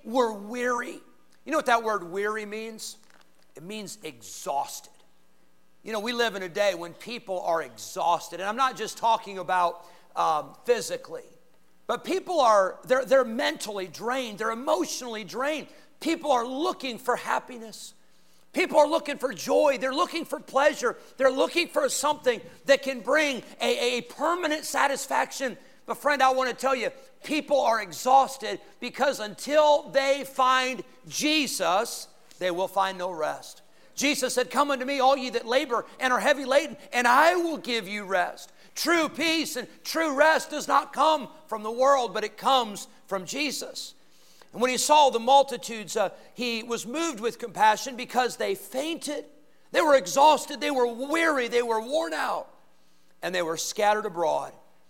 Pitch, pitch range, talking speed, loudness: 255 Hz, 215-285 Hz, 165 wpm, -26 LUFS